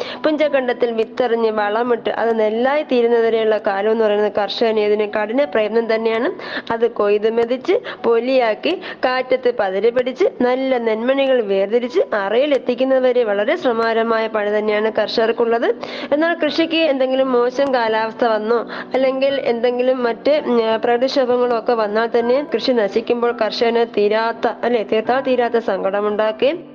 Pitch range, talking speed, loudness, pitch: 220-260 Hz, 115 wpm, -17 LUFS, 235 Hz